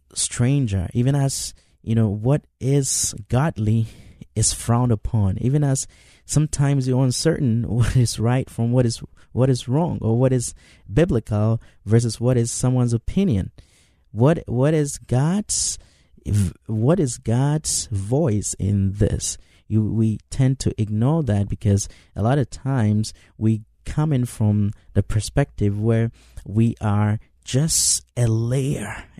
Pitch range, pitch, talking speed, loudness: 105-130 Hz, 115 Hz, 140 wpm, -21 LUFS